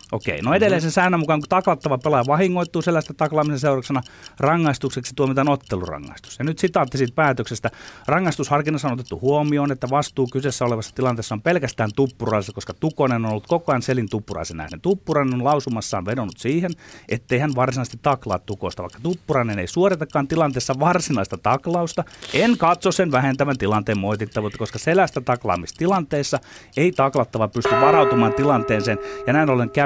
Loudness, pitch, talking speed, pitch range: -21 LUFS, 135 Hz, 155 wpm, 115-155 Hz